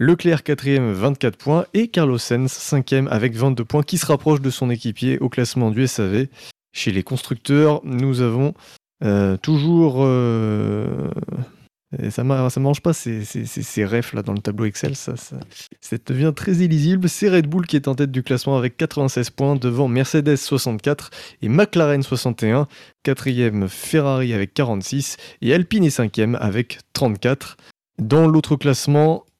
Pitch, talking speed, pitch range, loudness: 135 Hz, 155 wpm, 120-150 Hz, -19 LUFS